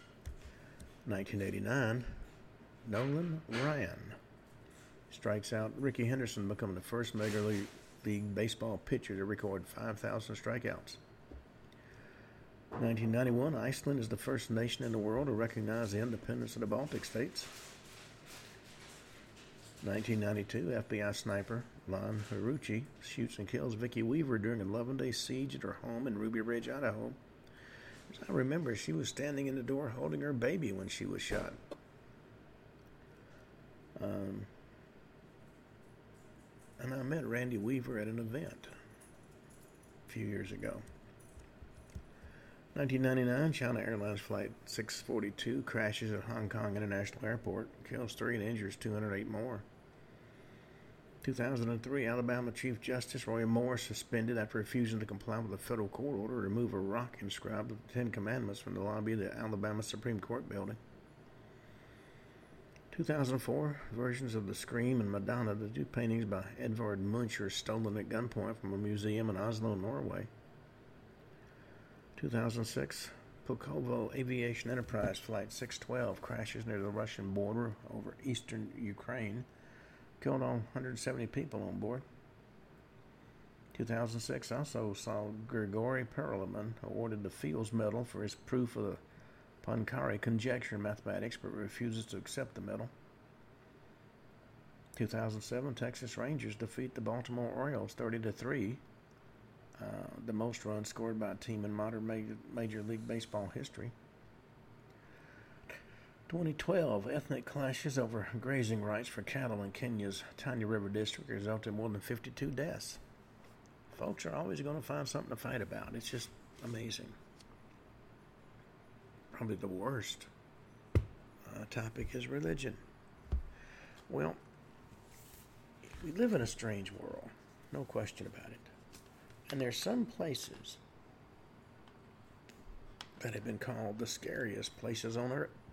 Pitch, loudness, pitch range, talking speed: 115 Hz, -39 LUFS, 105-125 Hz, 130 wpm